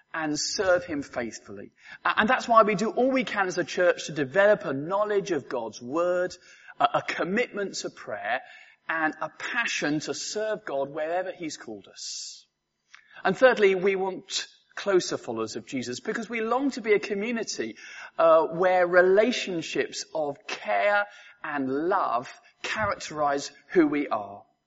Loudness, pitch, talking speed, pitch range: -26 LUFS, 190 Hz, 155 wpm, 155-230 Hz